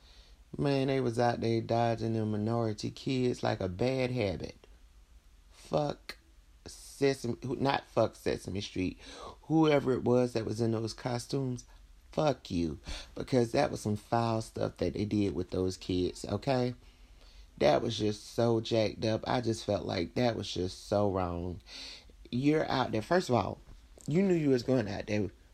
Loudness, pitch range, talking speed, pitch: -32 LUFS, 90-125 Hz, 165 wpm, 110 Hz